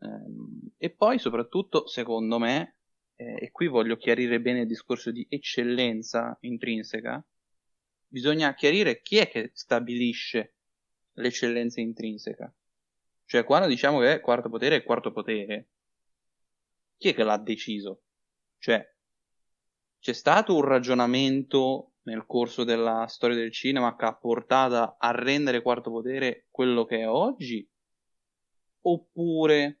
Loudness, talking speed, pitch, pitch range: -26 LUFS, 125 wpm, 120 Hz, 115-135 Hz